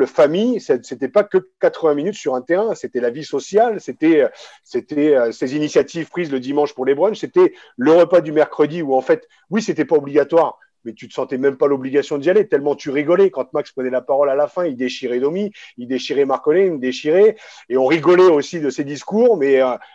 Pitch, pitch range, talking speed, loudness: 155 Hz, 140-210 Hz, 220 wpm, -17 LUFS